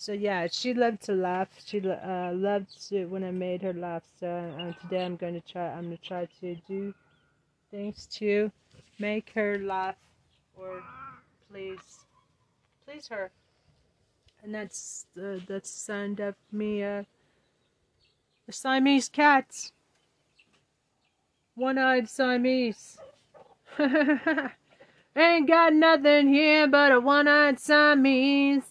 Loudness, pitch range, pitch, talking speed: -25 LUFS, 180-265 Hz, 205 Hz, 120 wpm